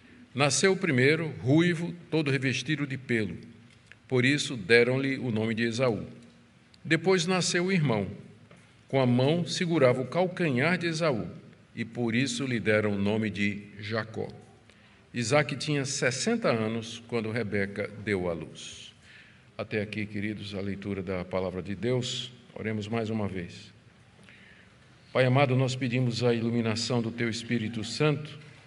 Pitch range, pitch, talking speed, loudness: 110-140 Hz, 120 Hz, 140 wpm, -28 LUFS